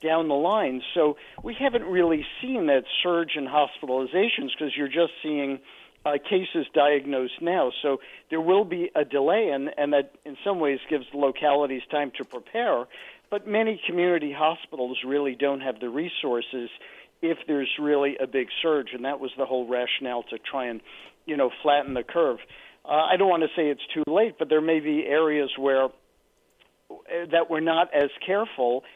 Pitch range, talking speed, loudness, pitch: 135-165 Hz, 180 wpm, -25 LUFS, 145 Hz